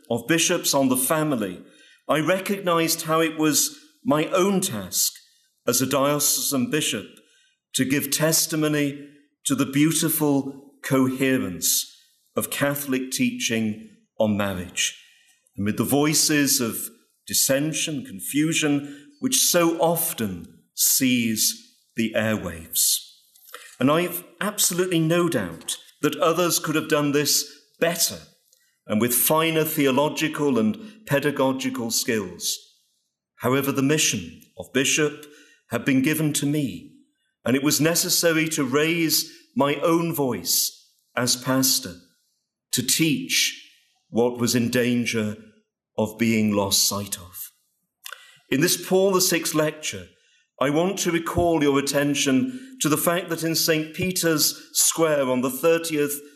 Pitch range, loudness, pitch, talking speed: 130-170 Hz, -22 LUFS, 150 Hz, 120 wpm